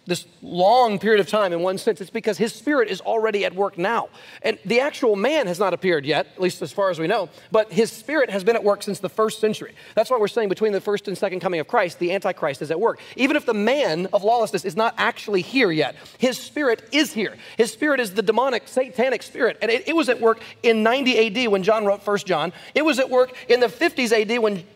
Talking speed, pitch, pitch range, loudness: 255 wpm, 220 Hz, 195-240 Hz, -21 LUFS